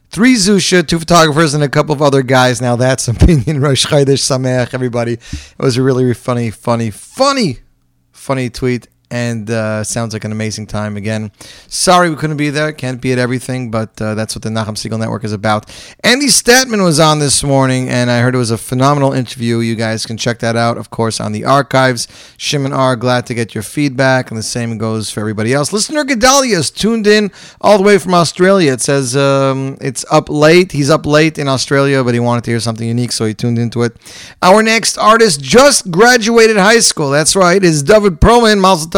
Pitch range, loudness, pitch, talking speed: 115-165 Hz, -12 LUFS, 130 Hz, 215 wpm